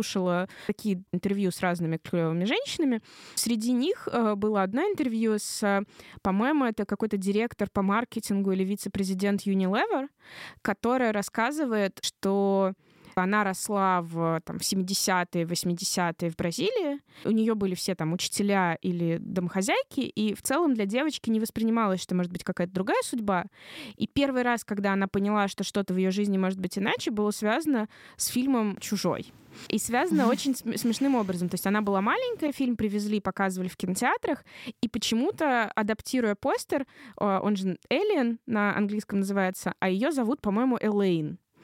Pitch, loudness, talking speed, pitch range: 205 Hz, -28 LUFS, 150 wpm, 190-235 Hz